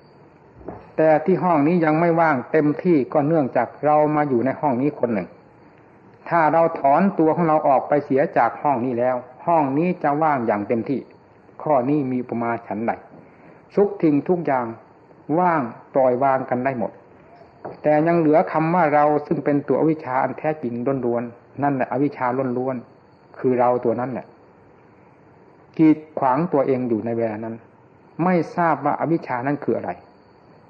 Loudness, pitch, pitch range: -20 LUFS, 145 Hz, 125-155 Hz